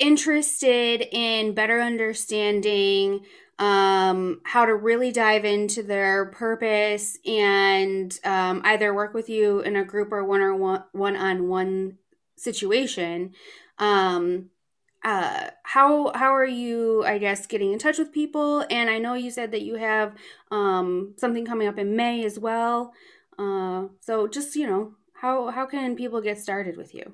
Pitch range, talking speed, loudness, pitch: 195-240 Hz, 155 wpm, -23 LUFS, 215 Hz